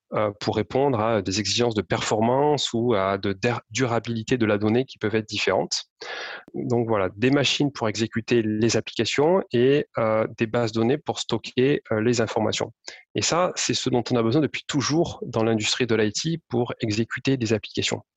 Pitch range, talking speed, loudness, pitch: 110-125 Hz, 170 wpm, -23 LUFS, 115 Hz